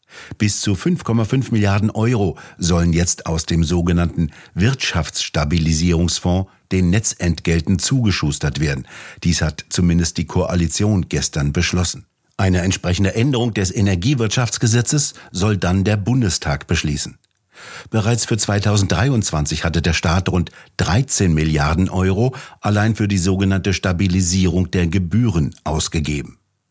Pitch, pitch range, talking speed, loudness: 95 Hz, 85-105 Hz, 110 wpm, -18 LUFS